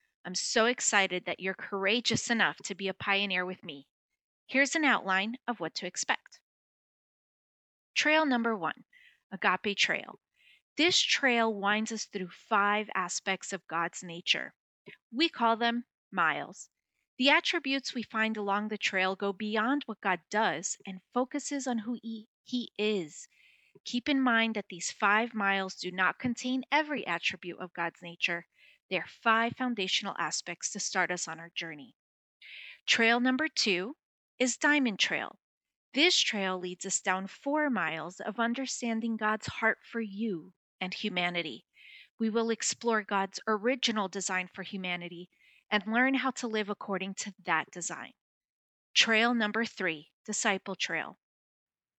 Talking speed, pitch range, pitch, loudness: 145 wpm, 185-240 Hz, 210 Hz, -30 LUFS